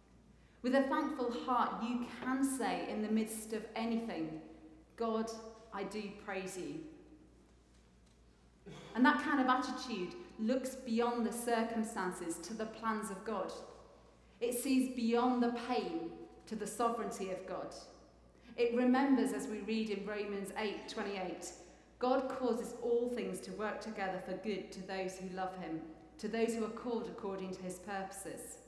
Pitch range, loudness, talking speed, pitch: 190-245 Hz, -37 LUFS, 155 wpm, 225 Hz